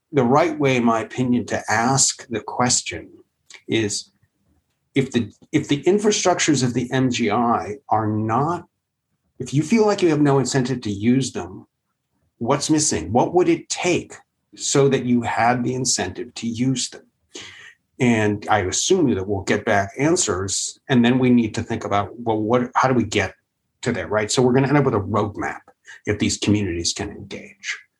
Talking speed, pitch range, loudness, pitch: 180 wpm, 110-140 Hz, -20 LUFS, 125 Hz